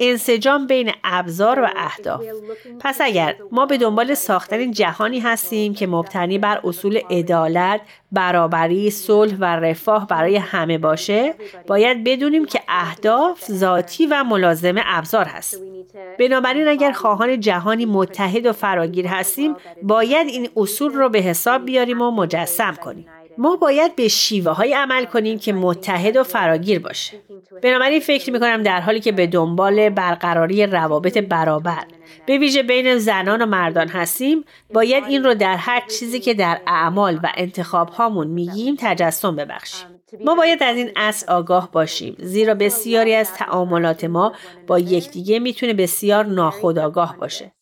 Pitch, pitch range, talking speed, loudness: 210 Hz, 180-240 Hz, 145 wpm, -18 LUFS